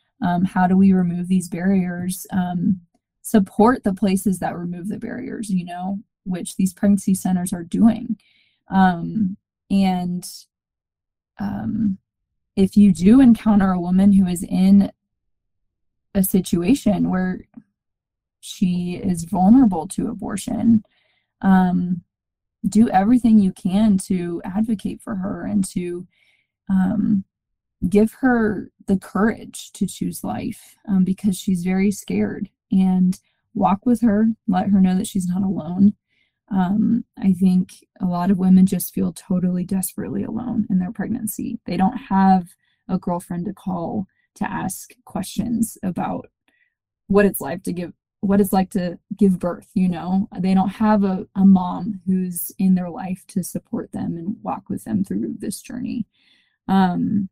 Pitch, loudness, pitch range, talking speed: 195 Hz, -20 LUFS, 185-215 Hz, 145 wpm